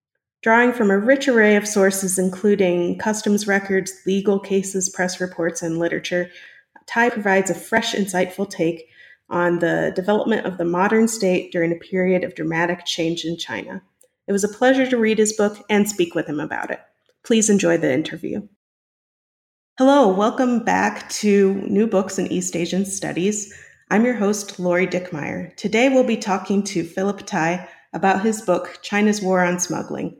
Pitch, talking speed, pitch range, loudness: 195 Hz, 165 wpm, 175-210 Hz, -20 LUFS